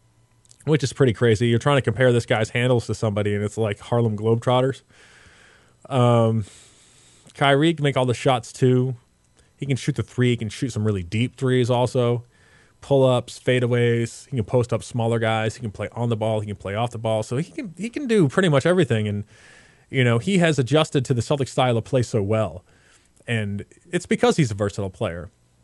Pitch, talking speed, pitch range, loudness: 120 Hz, 210 wpm, 110-135 Hz, -22 LUFS